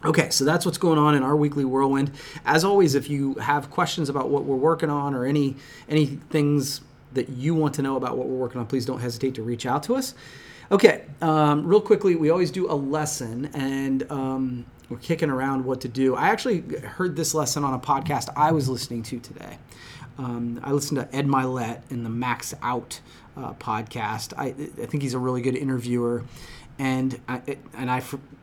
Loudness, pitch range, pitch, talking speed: -24 LUFS, 130-150 Hz, 140 Hz, 205 wpm